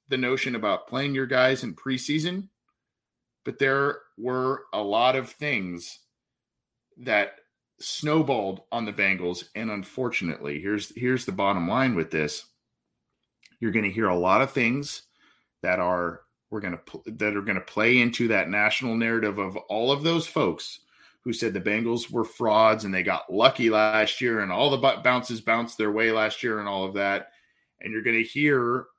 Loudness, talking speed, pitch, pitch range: -25 LUFS, 175 wpm, 115 Hz, 105-130 Hz